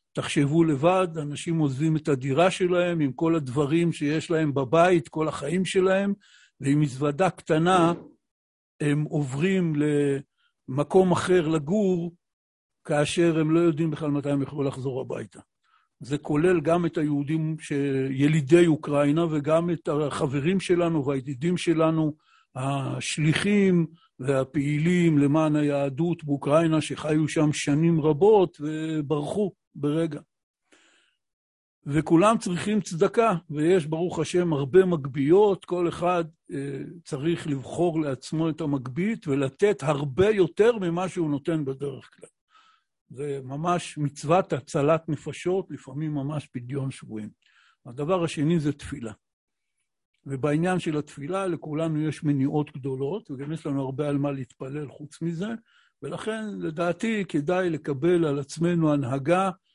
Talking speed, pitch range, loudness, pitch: 120 wpm, 145-175 Hz, -25 LUFS, 155 Hz